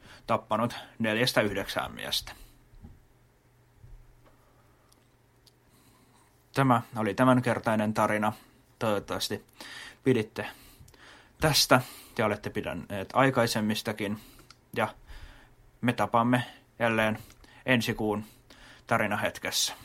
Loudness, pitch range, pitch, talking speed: -28 LUFS, 110-125 Hz, 115 Hz, 65 wpm